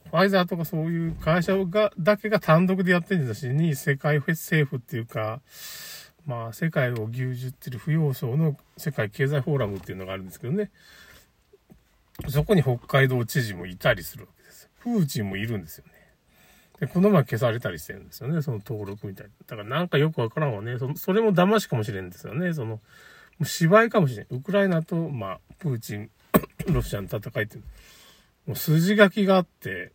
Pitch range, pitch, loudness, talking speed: 120-175 Hz, 145 Hz, -25 LUFS, 395 characters per minute